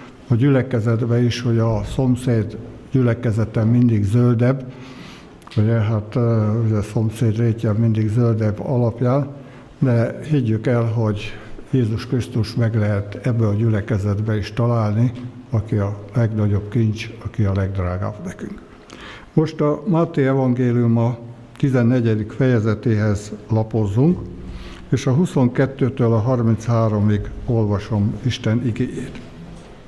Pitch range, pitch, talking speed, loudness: 110-125 Hz, 115 Hz, 110 wpm, -19 LUFS